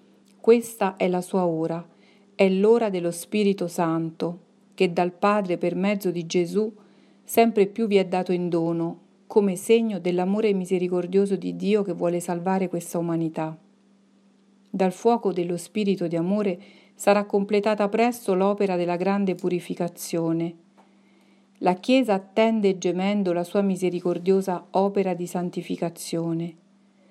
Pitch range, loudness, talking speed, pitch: 175-205 Hz, -24 LUFS, 130 wpm, 190 Hz